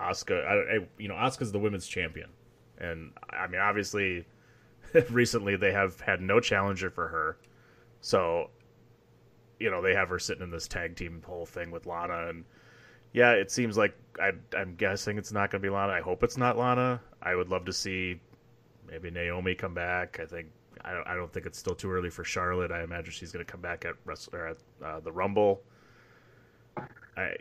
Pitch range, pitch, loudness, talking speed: 90-120 Hz, 100 Hz, -30 LUFS, 195 wpm